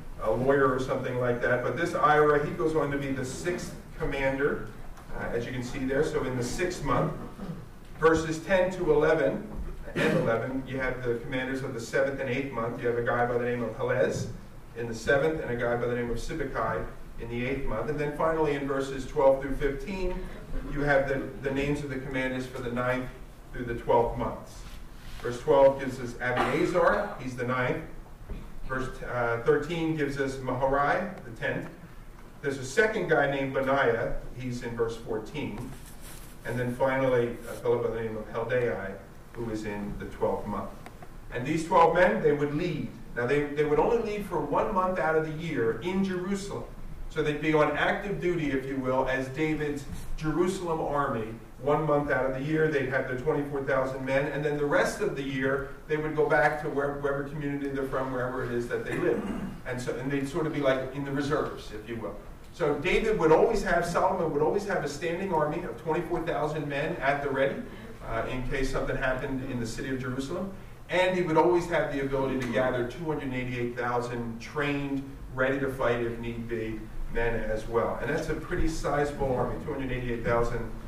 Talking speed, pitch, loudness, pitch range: 210 wpm, 135 Hz, -29 LUFS, 125-155 Hz